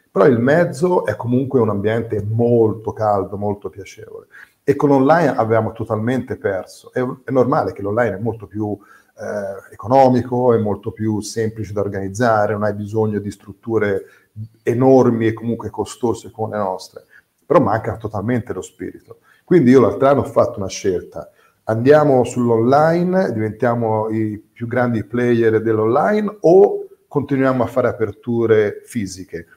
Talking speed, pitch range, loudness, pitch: 145 wpm, 105-130 Hz, -17 LUFS, 115 Hz